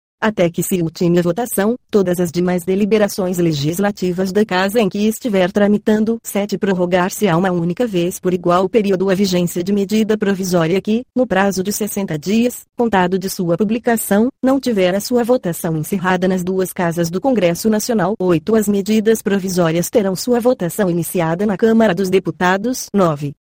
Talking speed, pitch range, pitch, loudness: 170 wpm, 180-220 Hz, 195 Hz, -16 LUFS